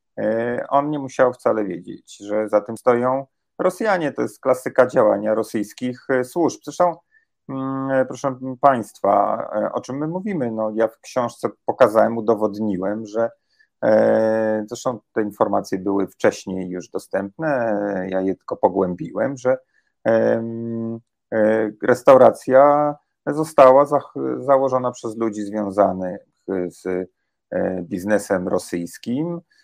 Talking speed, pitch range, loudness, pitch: 105 wpm, 105-135 Hz, -20 LUFS, 115 Hz